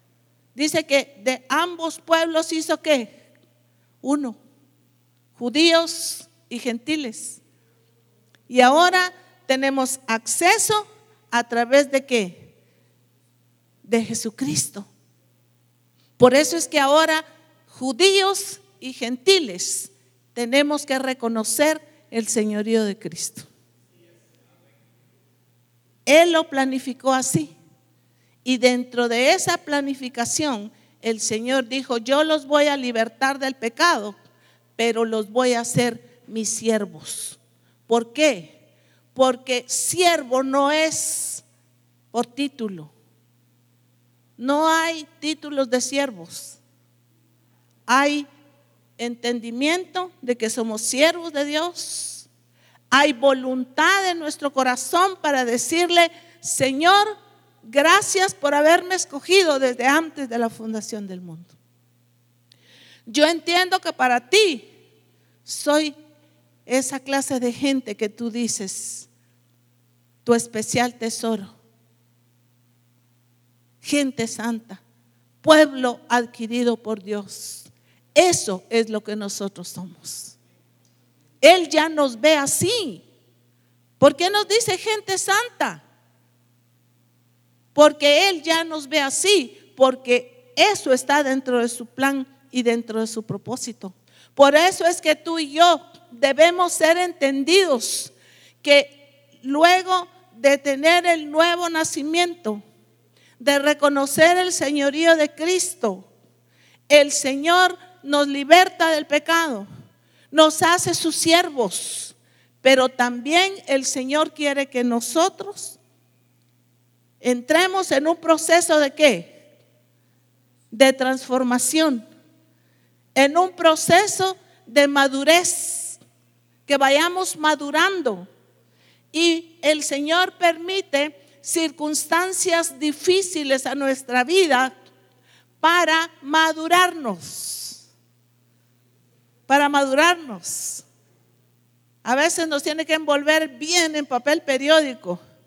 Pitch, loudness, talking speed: 260 Hz, -20 LUFS, 100 wpm